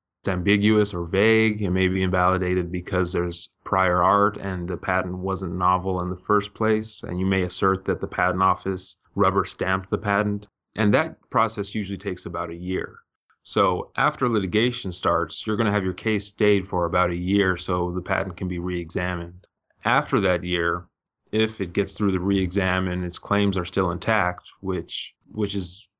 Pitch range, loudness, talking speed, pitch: 90-105 Hz, -24 LUFS, 185 wpm, 95 Hz